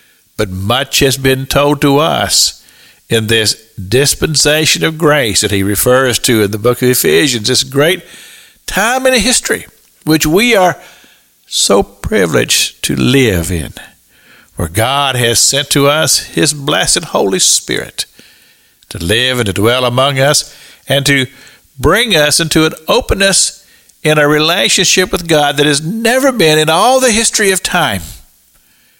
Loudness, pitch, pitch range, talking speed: -10 LUFS, 140 Hz, 120-155 Hz, 150 wpm